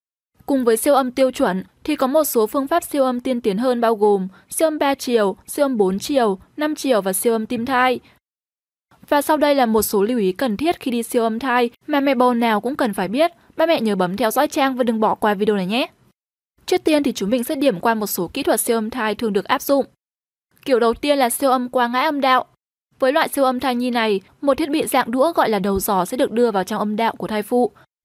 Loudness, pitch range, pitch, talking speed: -19 LUFS, 220-275 Hz, 250 Hz, 270 wpm